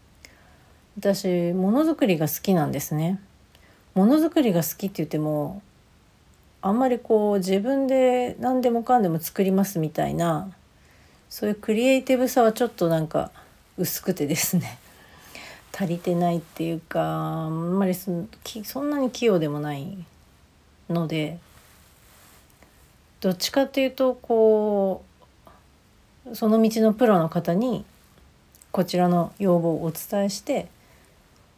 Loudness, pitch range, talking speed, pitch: -23 LUFS, 165-230 Hz, 235 characters per minute, 190 Hz